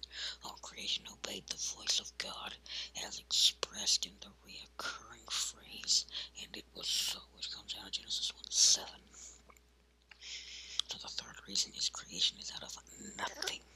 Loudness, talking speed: -35 LUFS, 140 wpm